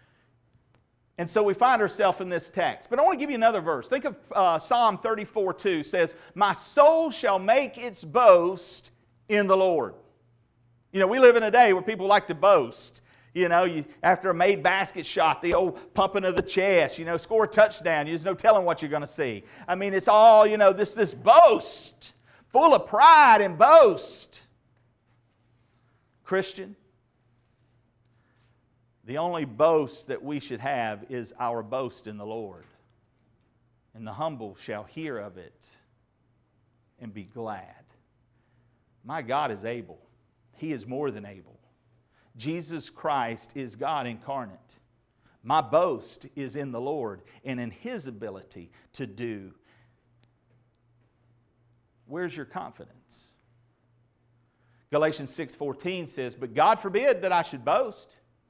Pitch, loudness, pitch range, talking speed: 130 Hz, -23 LUFS, 120-185 Hz, 150 wpm